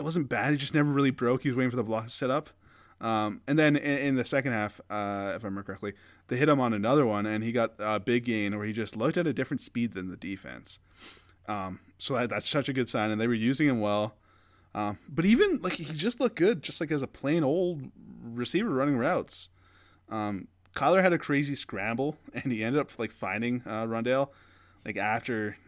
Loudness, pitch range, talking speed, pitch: -29 LUFS, 105-140 Hz, 235 wpm, 120 Hz